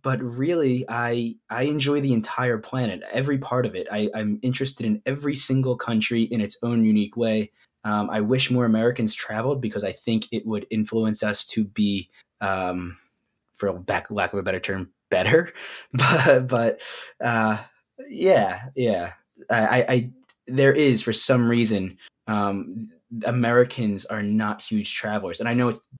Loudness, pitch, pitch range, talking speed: -23 LUFS, 115 Hz, 105-125 Hz, 165 wpm